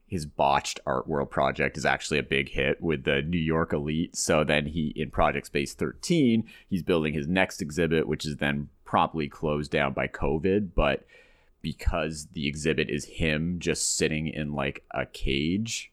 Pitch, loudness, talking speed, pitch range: 75 Hz, -27 LUFS, 175 wpm, 75-85 Hz